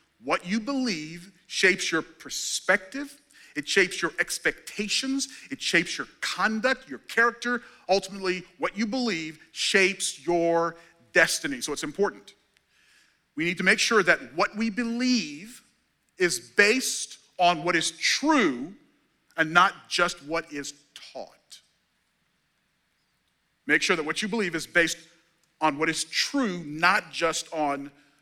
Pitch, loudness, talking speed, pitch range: 180 Hz, -25 LUFS, 130 wpm, 165-225 Hz